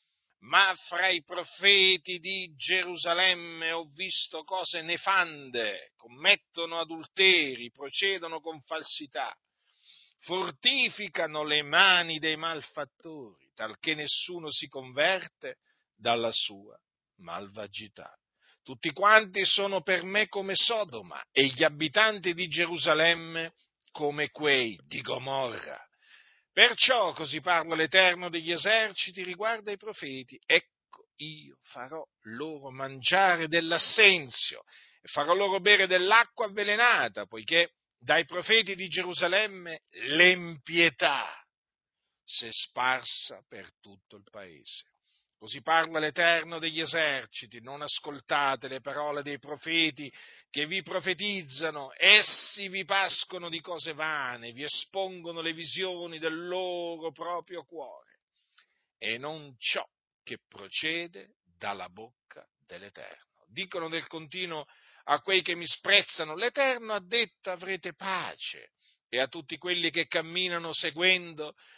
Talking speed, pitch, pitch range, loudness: 110 wpm, 165 Hz, 150-185 Hz, -26 LUFS